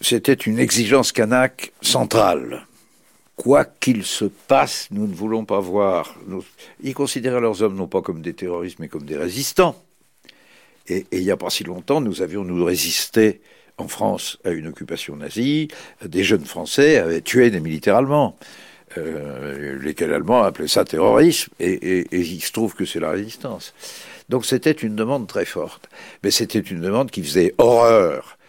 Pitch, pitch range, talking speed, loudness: 110 Hz, 90-130 Hz, 175 wpm, -19 LUFS